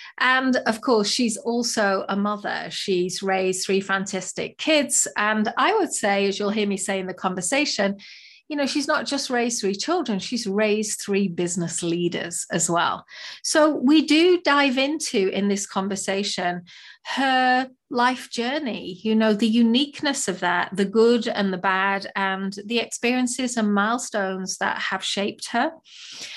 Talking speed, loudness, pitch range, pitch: 160 wpm, -22 LUFS, 195-255 Hz, 210 Hz